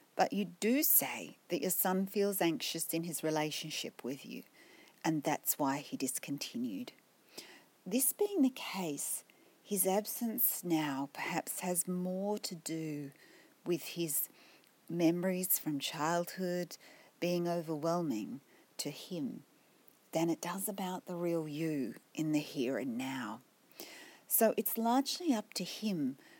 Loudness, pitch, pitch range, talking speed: -35 LUFS, 180 Hz, 165-220 Hz, 130 wpm